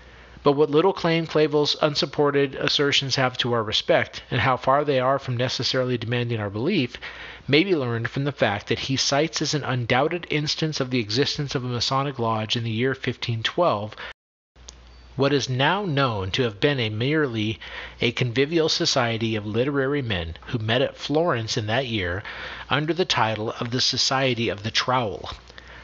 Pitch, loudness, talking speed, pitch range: 130 Hz, -23 LUFS, 180 wpm, 115-145 Hz